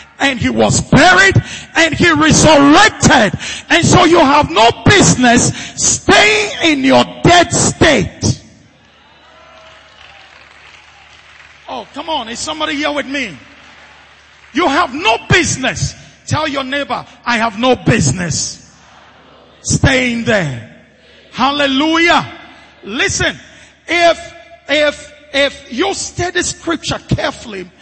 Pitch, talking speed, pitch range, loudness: 295 Hz, 105 wpm, 255-335 Hz, -12 LUFS